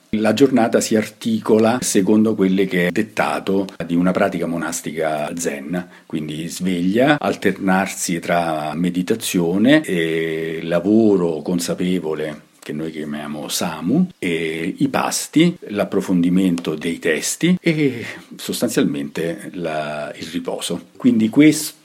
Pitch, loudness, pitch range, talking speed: 90 Hz, -19 LUFS, 80-110 Hz, 105 wpm